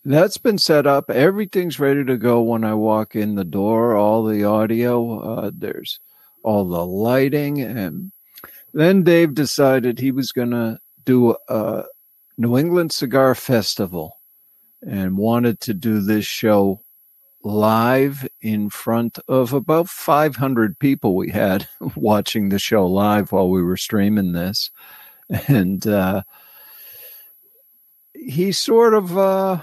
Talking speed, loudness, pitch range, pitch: 135 wpm, -18 LUFS, 105-145 Hz, 120 Hz